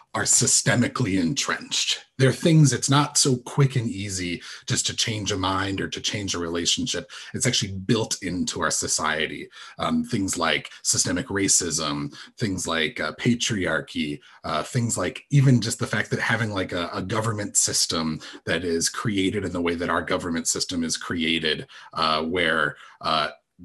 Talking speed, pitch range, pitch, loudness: 165 wpm, 85-120 Hz, 100 Hz, -23 LUFS